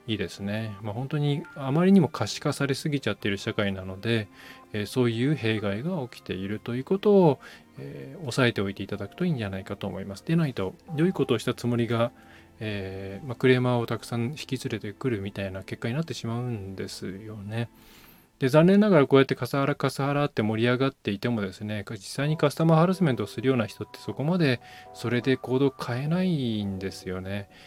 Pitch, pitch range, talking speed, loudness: 120 Hz, 105-140 Hz, 450 characters per minute, -27 LUFS